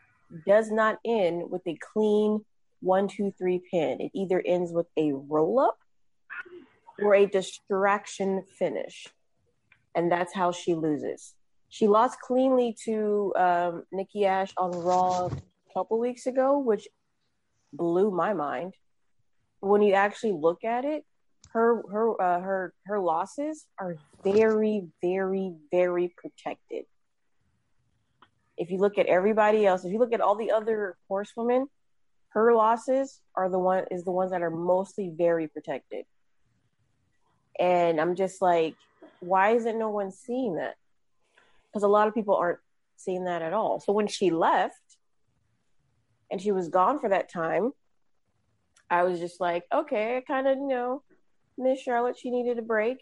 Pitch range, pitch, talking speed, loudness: 180-225 Hz, 195 Hz, 150 wpm, -27 LUFS